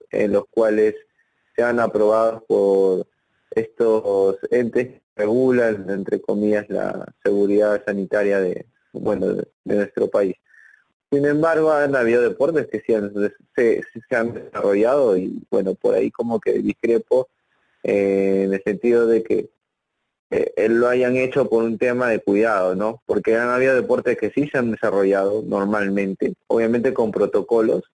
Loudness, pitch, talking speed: -20 LUFS, 120 Hz, 150 wpm